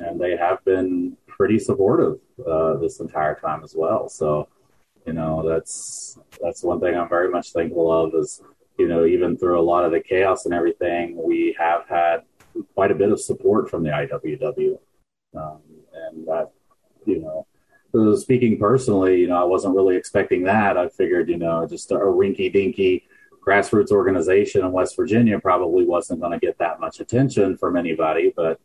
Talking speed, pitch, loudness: 180 wpm, 105 Hz, -20 LUFS